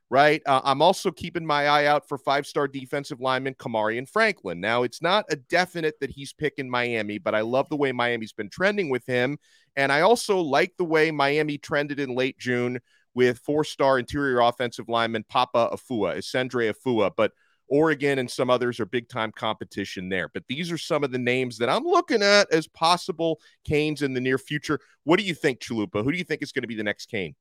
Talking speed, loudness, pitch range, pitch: 210 wpm, -24 LUFS, 120-155 Hz, 140 Hz